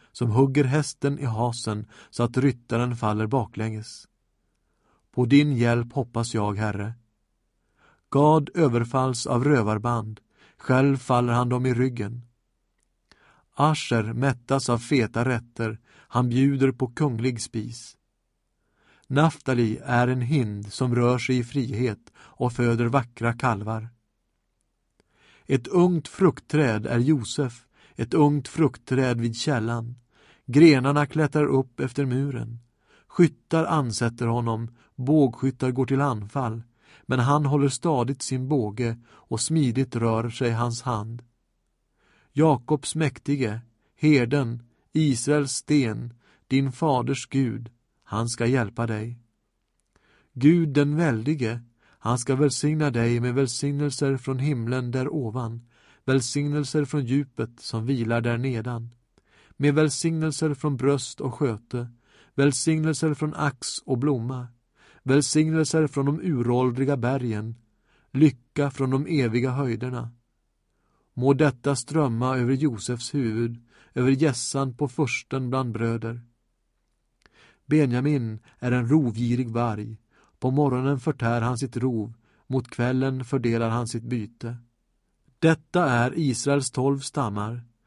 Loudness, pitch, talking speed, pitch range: -24 LUFS, 125 Hz, 115 wpm, 115-140 Hz